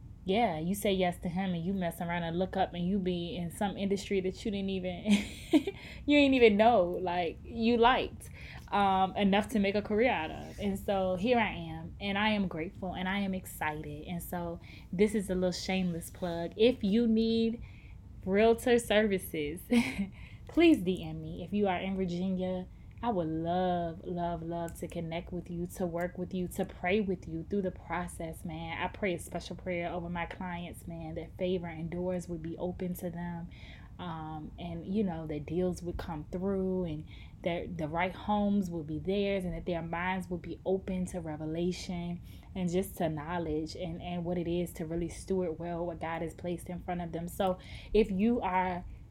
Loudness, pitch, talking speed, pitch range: -32 LUFS, 180 Hz, 200 wpm, 170-195 Hz